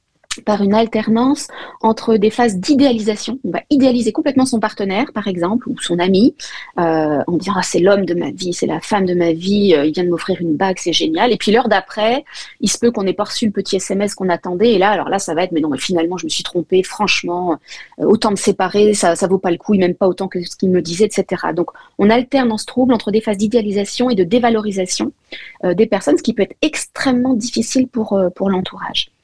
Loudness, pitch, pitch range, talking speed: -16 LUFS, 205 Hz, 180-230 Hz, 245 wpm